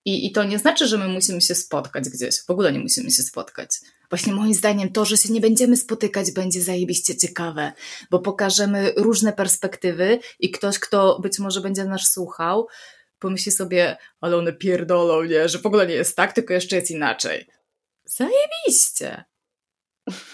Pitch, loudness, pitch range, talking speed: 195 Hz, -19 LUFS, 180-215 Hz, 170 wpm